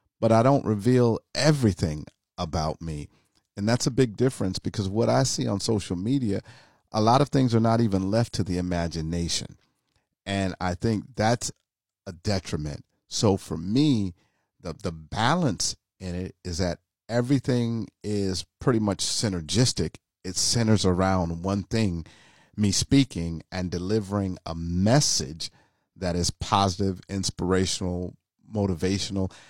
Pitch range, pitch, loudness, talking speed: 90-115 Hz, 100 Hz, -26 LUFS, 135 wpm